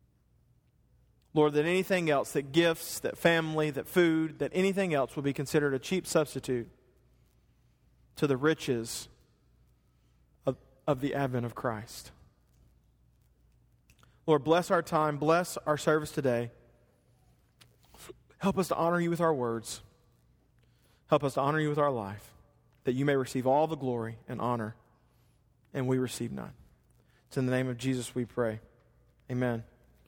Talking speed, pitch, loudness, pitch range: 150 wpm, 130 Hz, -30 LUFS, 120-155 Hz